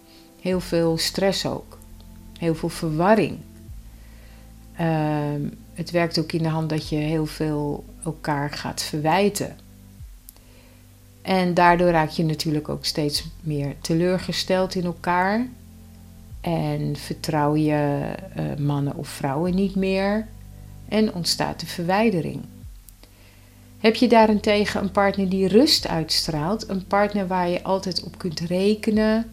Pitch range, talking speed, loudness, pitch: 140-185 Hz, 125 wpm, -22 LUFS, 160 Hz